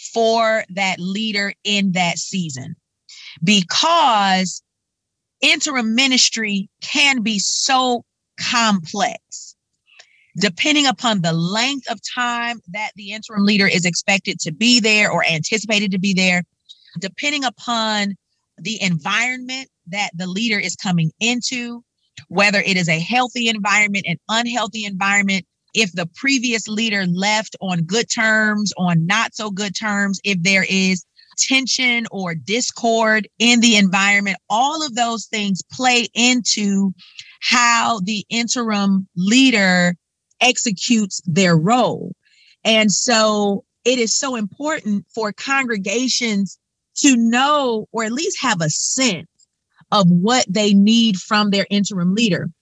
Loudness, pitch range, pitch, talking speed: -17 LUFS, 190-235 Hz, 210 Hz, 125 wpm